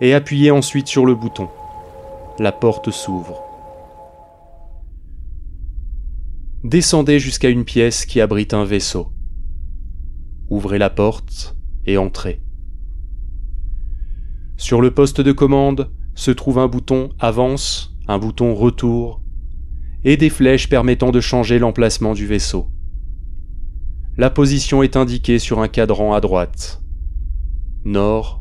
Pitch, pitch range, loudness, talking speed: 100 Hz, 75-125 Hz, -16 LUFS, 115 wpm